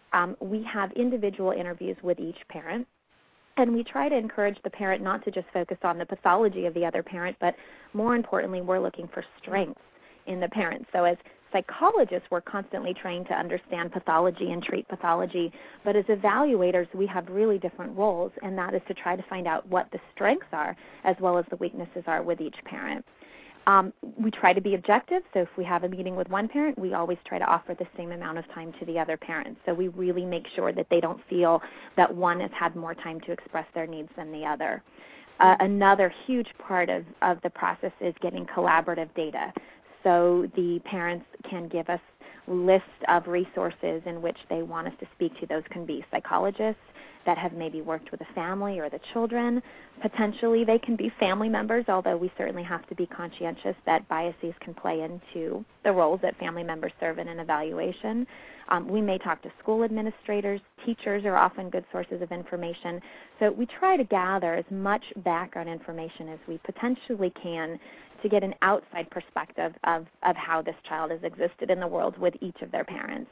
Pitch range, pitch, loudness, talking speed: 170-205 Hz, 180 Hz, -28 LUFS, 200 wpm